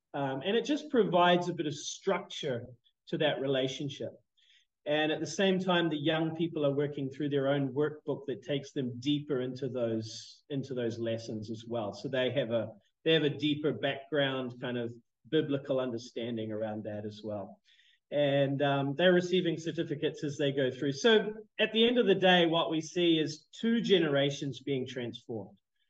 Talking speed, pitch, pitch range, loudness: 180 wpm, 145 Hz, 125-165 Hz, -31 LUFS